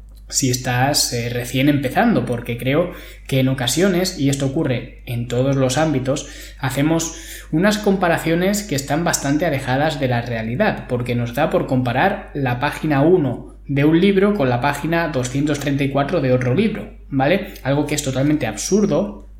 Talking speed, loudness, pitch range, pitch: 160 wpm, -19 LUFS, 130-165 Hz, 140 Hz